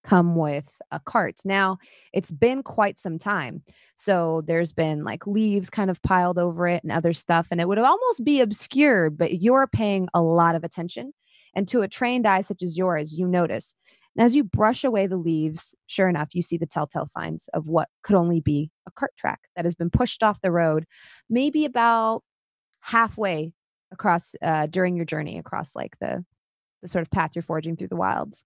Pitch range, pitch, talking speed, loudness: 165-210 Hz, 180 Hz, 200 wpm, -23 LUFS